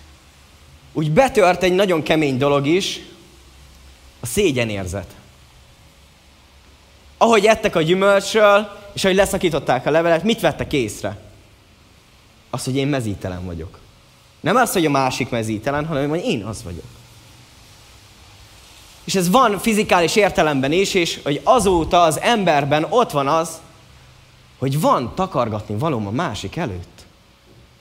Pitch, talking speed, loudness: 140 Hz, 125 wpm, -18 LUFS